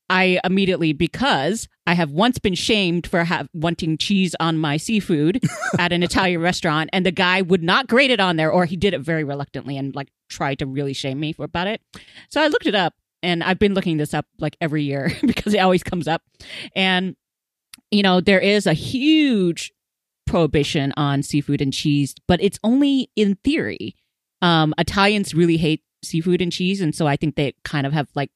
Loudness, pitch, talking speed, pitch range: -20 LUFS, 175 Hz, 205 wpm, 150-195 Hz